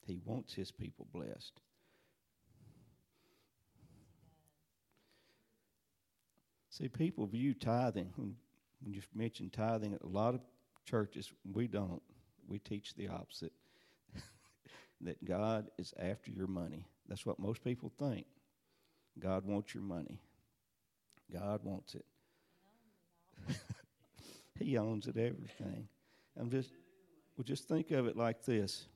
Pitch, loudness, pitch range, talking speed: 110 Hz, -42 LUFS, 95-120 Hz, 110 wpm